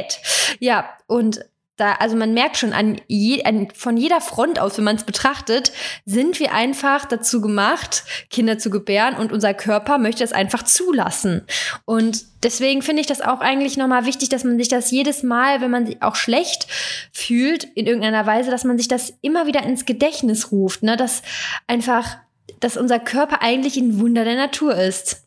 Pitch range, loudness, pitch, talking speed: 220-275 Hz, -18 LUFS, 245 Hz, 185 wpm